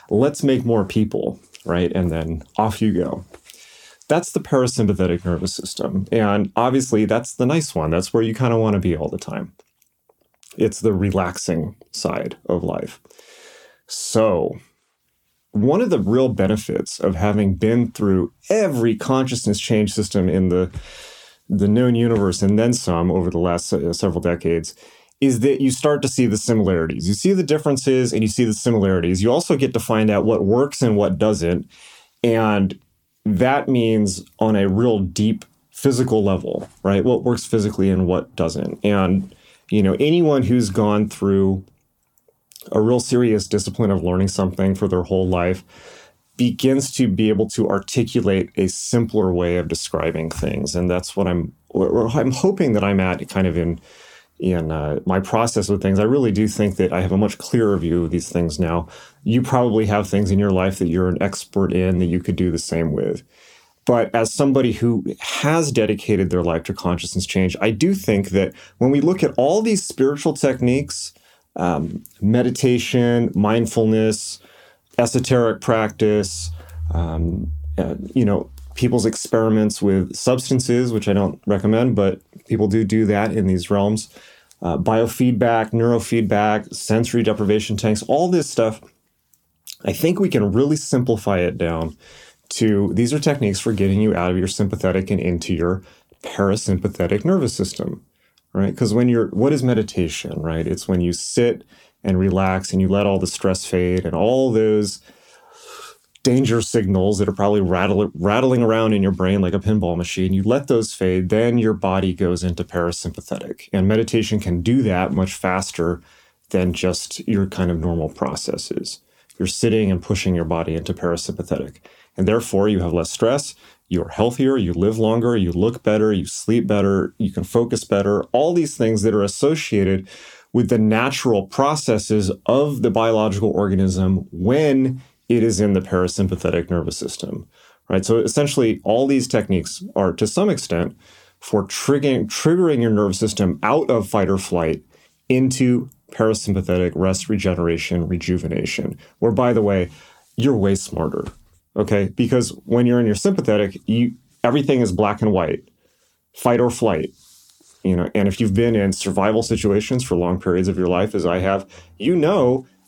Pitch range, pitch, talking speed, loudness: 95-120 Hz, 105 Hz, 170 wpm, -19 LUFS